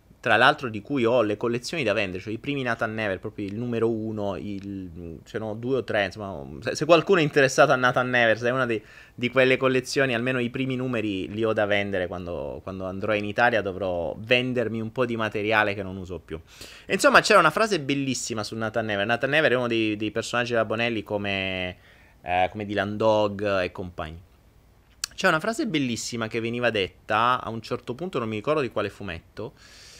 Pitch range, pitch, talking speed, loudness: 100-125 Hz, 110 Hz, 205 wpm, -24 LUFS